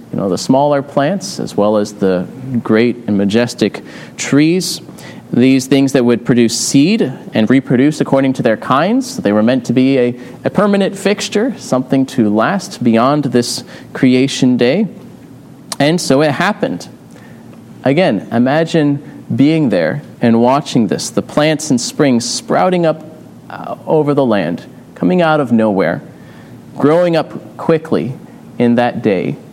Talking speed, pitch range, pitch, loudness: 145 wpm, 120-165 Hz, 140 Hz, -13 LUFS